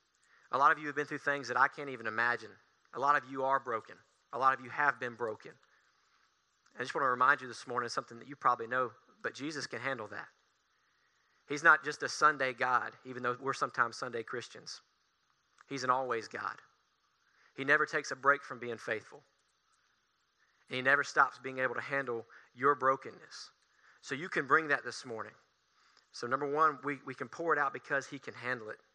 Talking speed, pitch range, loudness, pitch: 205 wpm, 125-145 Hz, -33 LUFS, 135 Hz